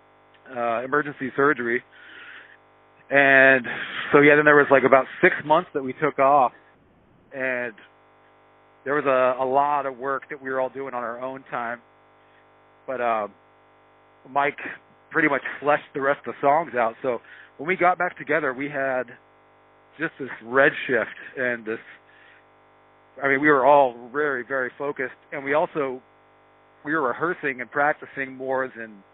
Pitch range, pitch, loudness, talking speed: 100-140 Hz, 130 Hz, -22 LUFS, 155 wpm